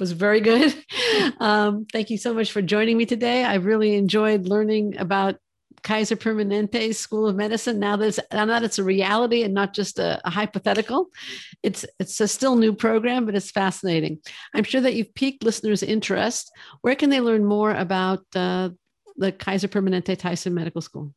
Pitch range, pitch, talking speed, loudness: 195-225 Hz, 215 Hz, 185 wpm, -22 LUFS